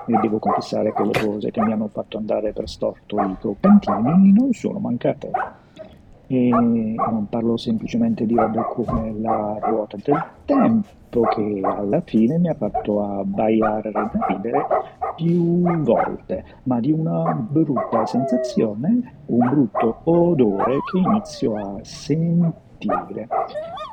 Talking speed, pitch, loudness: 130 wpm, 140 Hz, -20 LUFS